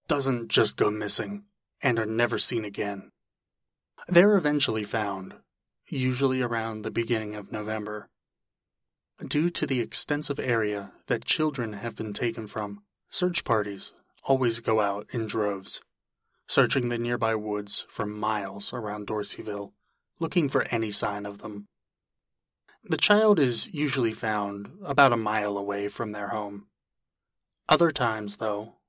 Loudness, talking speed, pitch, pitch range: -27 LUFS, 135 wpm, 110 Hz, 105-130 Hz